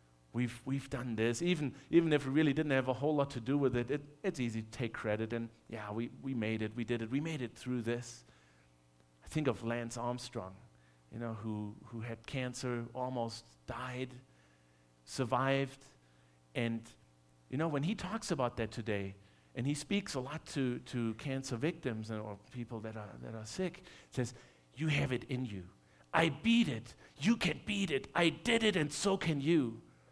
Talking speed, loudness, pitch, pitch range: 195 wpm, -36 LUFS, 120 Hz, 110-145 Hz